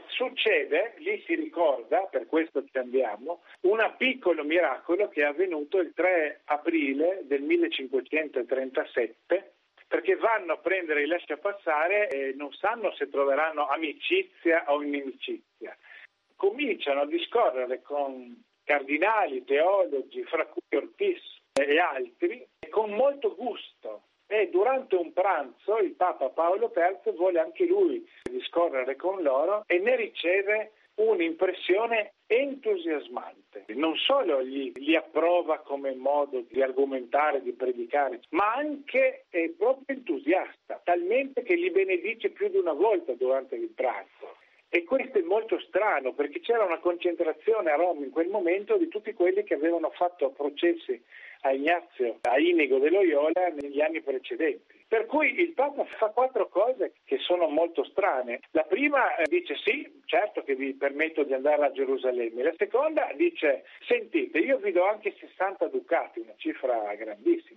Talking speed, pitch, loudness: 140 wpm, 225 Hz, -27 LUFS